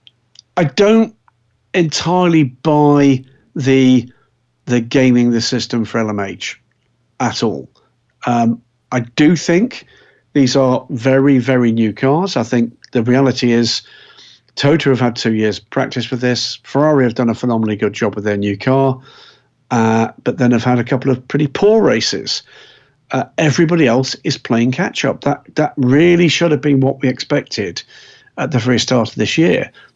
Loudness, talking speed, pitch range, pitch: -15 LUFS, 160 wpm, 120-140 Hz, 125 Hz